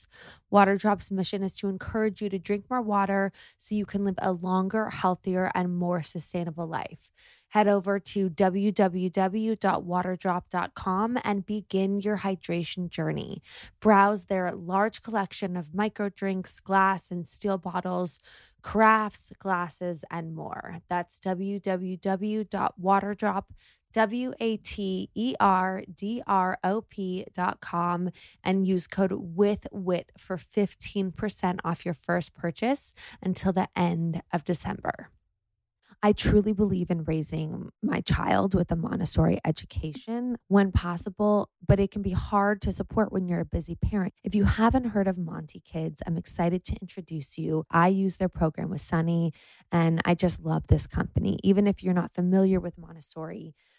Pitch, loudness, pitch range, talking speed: 190 Hz, -28 LUFS, 175-205 Hz, 145 wpm